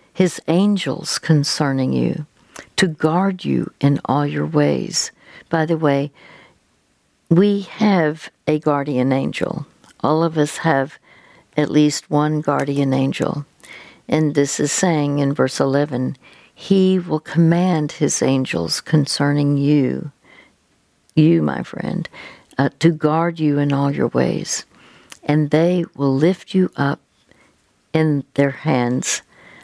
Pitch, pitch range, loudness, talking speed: 150 Hz, 140-165 Hz, -19 LUFS, 125 wpm